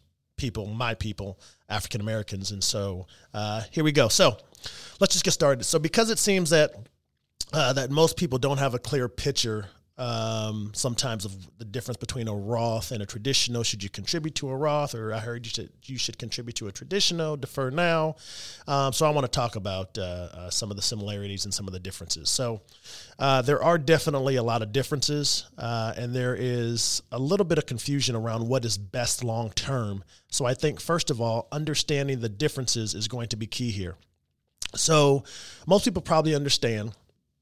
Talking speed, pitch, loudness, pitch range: 195 wpm, 120 Hz, -26 LUFS, 105-140 Hz